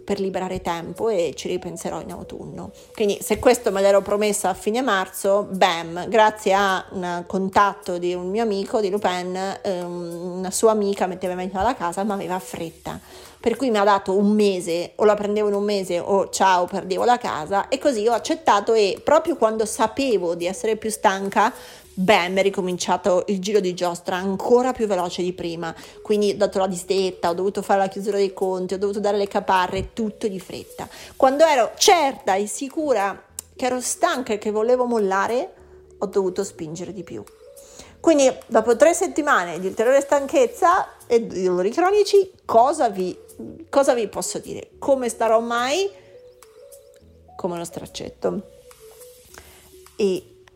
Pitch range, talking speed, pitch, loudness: 185-250 Hz, 170 wpm, 205 Hz, -21 LUFS